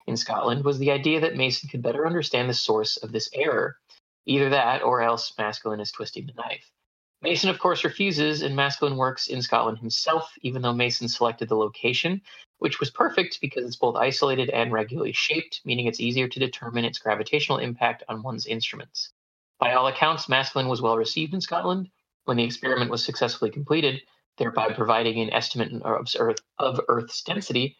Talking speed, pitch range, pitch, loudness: 180 wpm, 115-150 Hz, 125 Hz, -25 LUFS